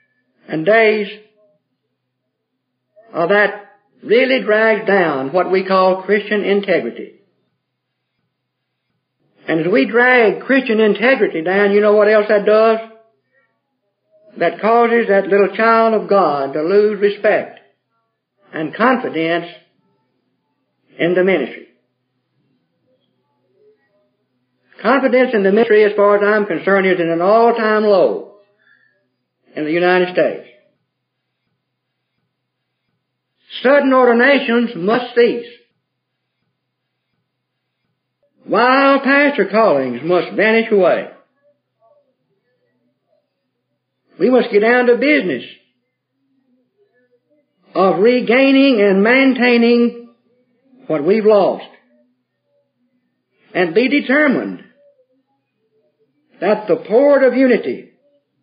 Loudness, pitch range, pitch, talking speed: -14 LUFS, 195-250 Hz, 220 Hz, 90 wpm